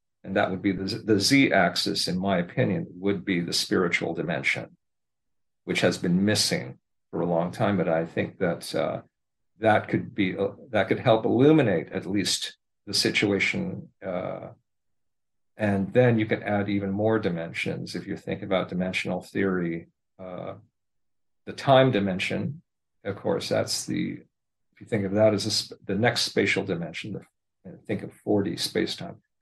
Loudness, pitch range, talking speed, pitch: -25 LUFS, 95-110 Hz, 160 wpm, 100 Hz